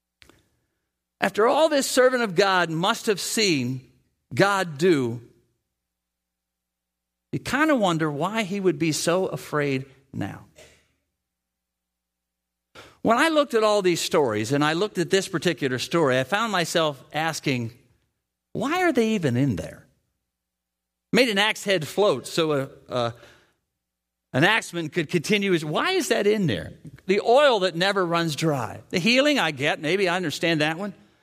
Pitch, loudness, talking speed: 160 Hz, -23 LUFS, 150 wpm